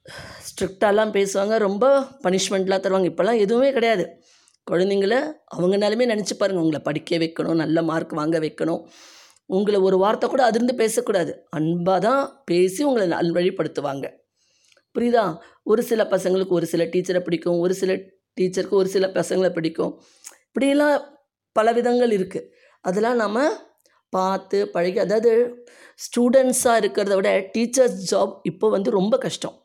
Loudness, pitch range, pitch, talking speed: -21 LUFS, 180-235 Hz, 200 Hz, 125 wpm